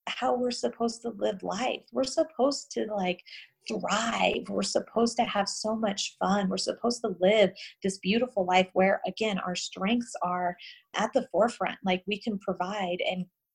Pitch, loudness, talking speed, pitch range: 205 Hz, -29 LUFS, 170 wpm, 185-235 Hz